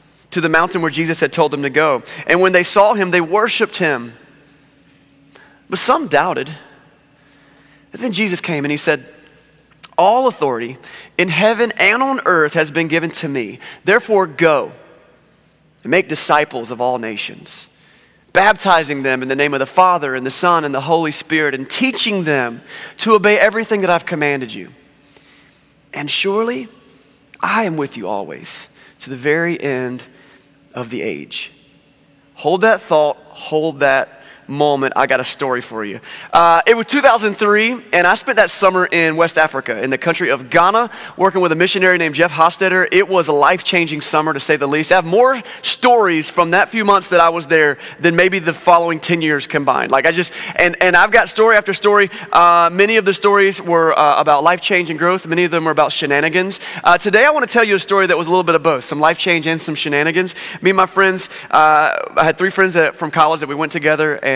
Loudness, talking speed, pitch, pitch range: -14 LUFS, 205 wpm, 165 Hz, 145-190 Hz